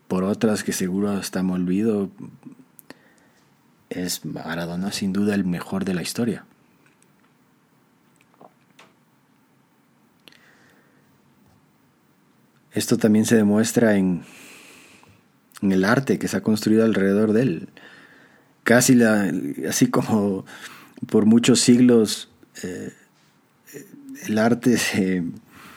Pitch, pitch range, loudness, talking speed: 105 Hz, 95-110 Hz, -21 LUFS, 100 wpm